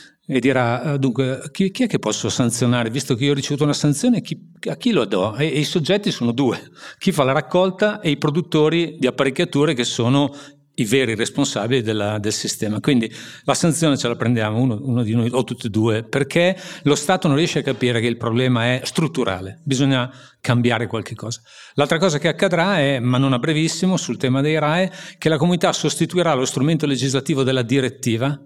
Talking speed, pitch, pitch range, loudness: 200 wpm, 140 Hz, 120-160 Hz, -19 LUFS